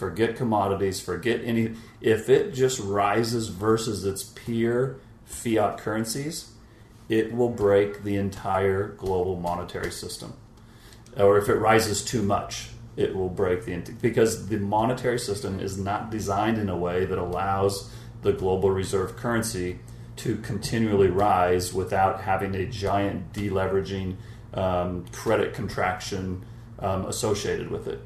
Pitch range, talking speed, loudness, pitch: 95-115 Hz, 135 wpm, -26 LUFS, 105 Hz